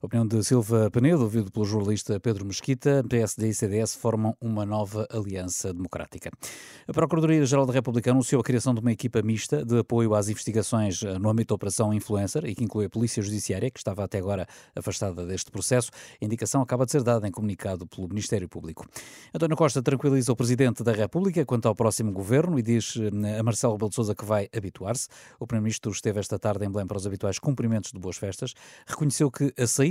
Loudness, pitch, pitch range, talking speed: -26 LUFS, 110 Hz, 105-125 Hz, 205 wpm